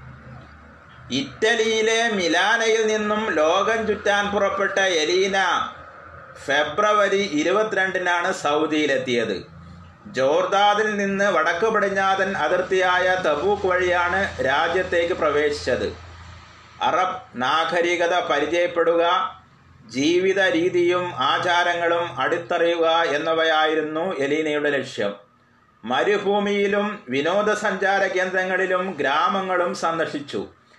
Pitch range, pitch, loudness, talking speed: 170-205 Hz, 185 Hz, -21 LUFS, 65 wpm